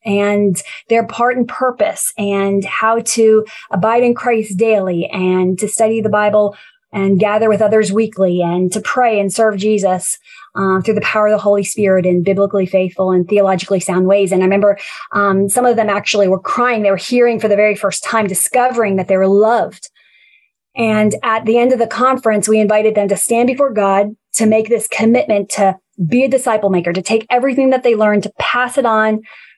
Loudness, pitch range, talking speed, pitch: -14 LUFS, 195-230 Hz, 200 wpm, 215 Hz